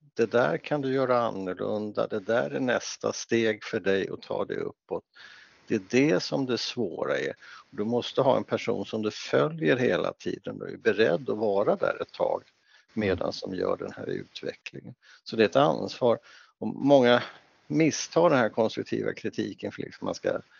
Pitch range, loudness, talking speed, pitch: 110-150 Hz, -27 LUFS, 190 wpm, 120 Hz